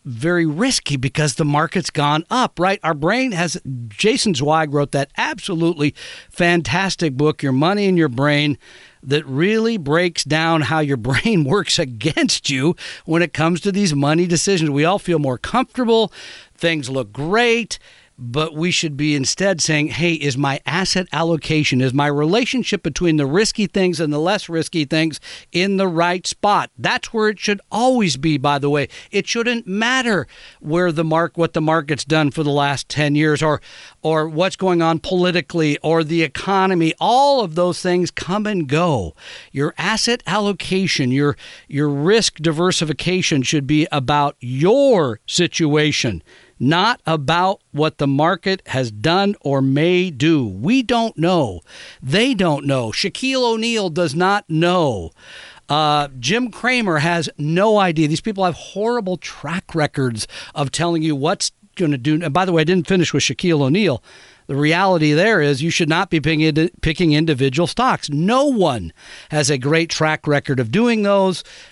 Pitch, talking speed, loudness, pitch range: 165 Hz, 165 wpm, -18 LUFS, 150-190 Hz